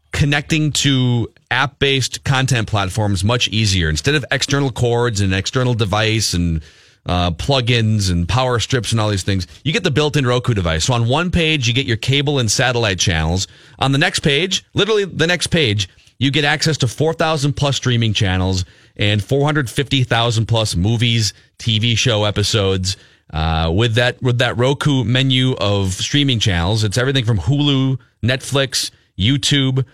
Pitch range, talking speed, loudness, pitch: 105-140 Hz, 170 wpm, -16 LUFS, 120 Hz